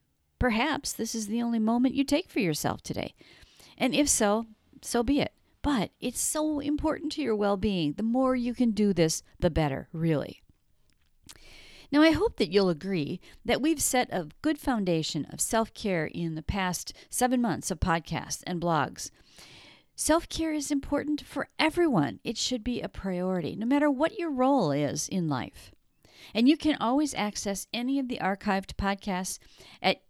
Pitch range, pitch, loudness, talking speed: 175-280 Hz, 225 Hz, -28 LUFS, 175 wpm